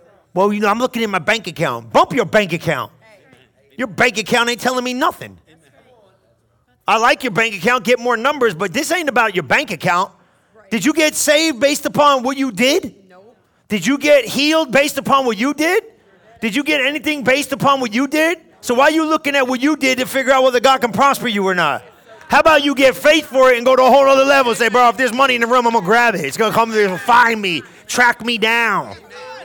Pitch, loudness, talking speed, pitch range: 255 Hz, -15 LUFS, 245 wpm, 230-280 Hz